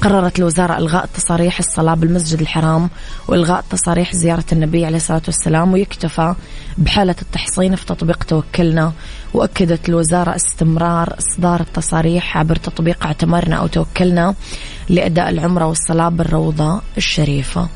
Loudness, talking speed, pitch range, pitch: -15 LUFS, 120 wpm, 160-180 Hz, 170 Hz